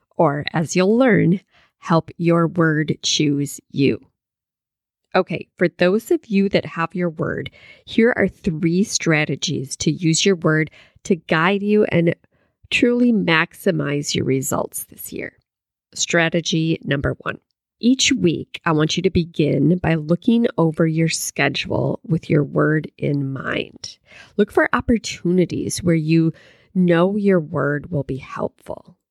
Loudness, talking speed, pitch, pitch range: -19 LUFS, 140 wpm, 170 Hz, 160-190 Hz